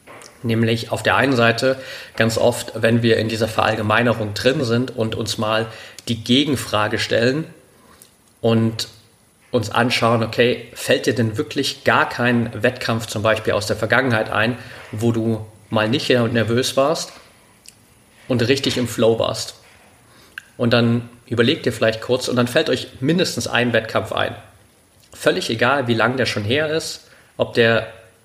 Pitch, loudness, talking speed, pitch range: 115 Hz, -19 LUFS, 155 wpm, 110-125 Hz